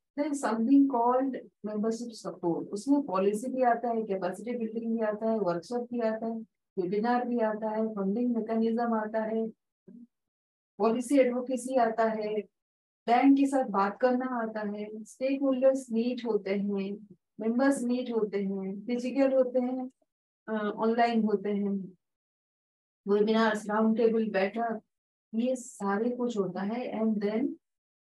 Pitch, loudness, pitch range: 225 Hz, -29 LUFS, 210-245 Hz